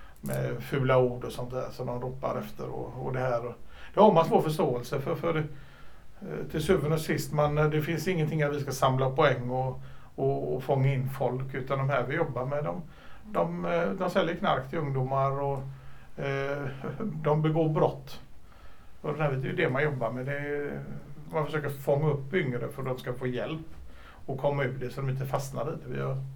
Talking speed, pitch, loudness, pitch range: 210 wpm, 135 Hz, -29 LUFS, 125-155 Hz